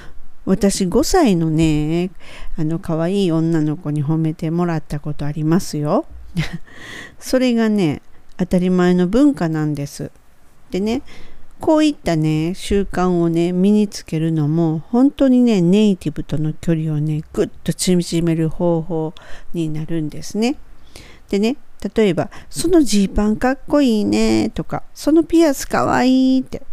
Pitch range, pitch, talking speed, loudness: 155-215 Hz, 175 Hz, 270 characters per minute, -18 LUFS